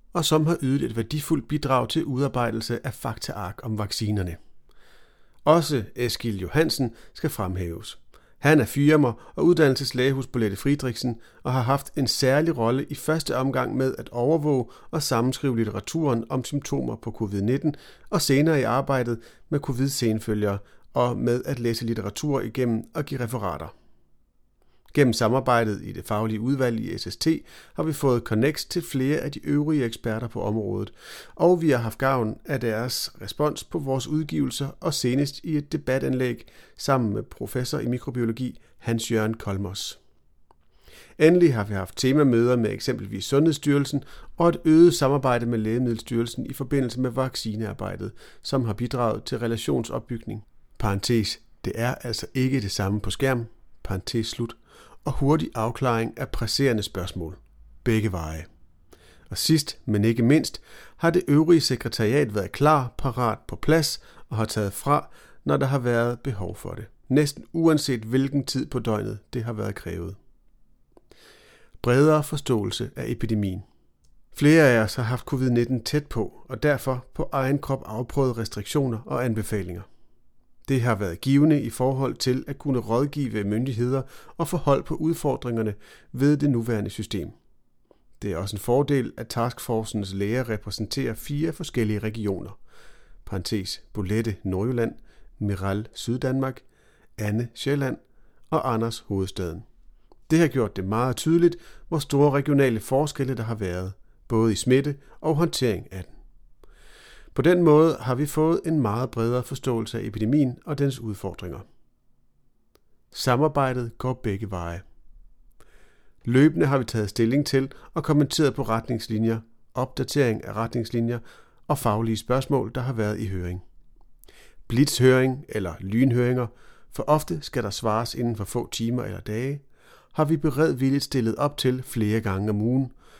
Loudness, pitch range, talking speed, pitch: -25 LUFS, 110-140 Hz, 150 wpm, 125 Hz